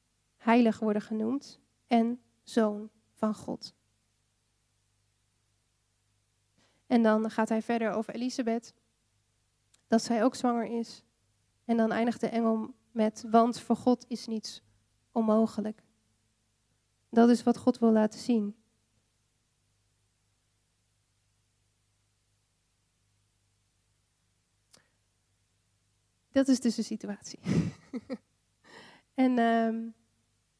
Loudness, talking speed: -29 LUFS, 90 wpm